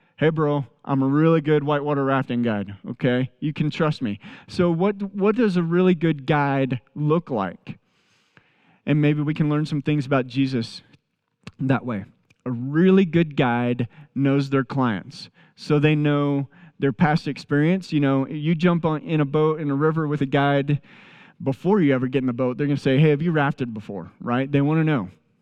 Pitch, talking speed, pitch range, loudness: 145 Hz, 195 wpm, 135-160 Hz, -22 LUFS